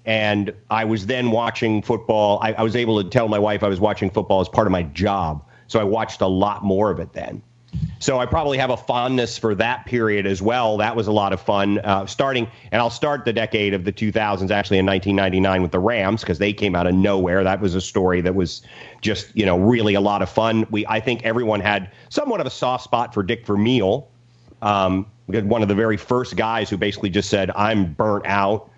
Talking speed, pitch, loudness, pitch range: 240 wpm, 105 Hz, -20 LUFS, 95-115 Hz